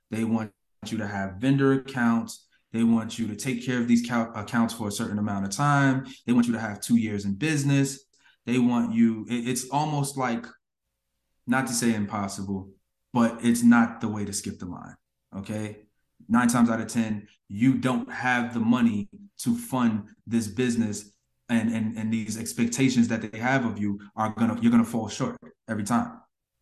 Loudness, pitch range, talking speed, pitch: -26 LUFS, 110-125 Hz, 190 wpm, 115 Hz